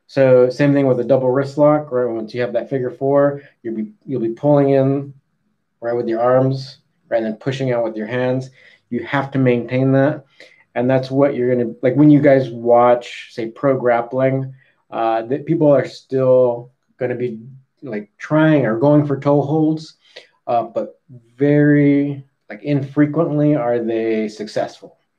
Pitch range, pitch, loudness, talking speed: 120-145 Hz, 135 Hz, -17 LUFS, 175 wpm